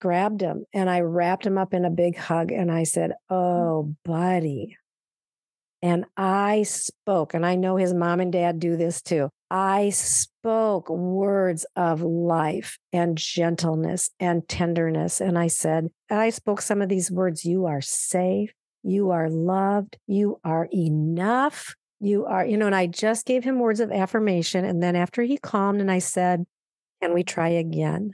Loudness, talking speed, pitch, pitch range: -24 LUFS, 175 wpm, 180 Hz, 170-200 Hz